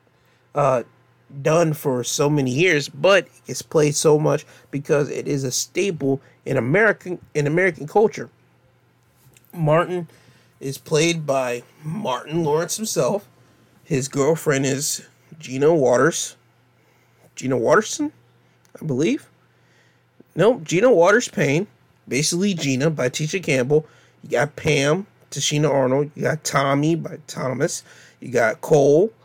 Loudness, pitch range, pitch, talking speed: -20 LUFS, 135-165 Hz, 150 Hz, 120 wpm